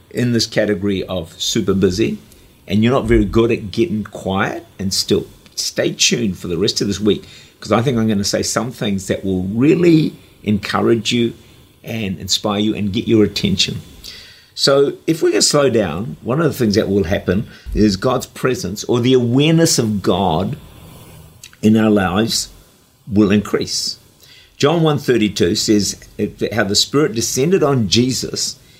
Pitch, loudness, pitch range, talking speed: 110 Hz, -16 LUFS, 100-120 Hz, 170 wpm